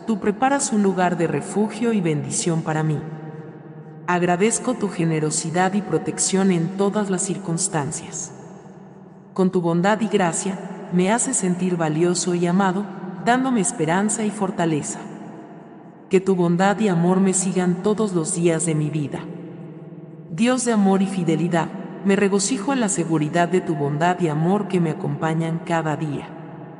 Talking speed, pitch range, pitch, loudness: 150 wpm, 165-195 Hz, 180 Hz, -21 LUFS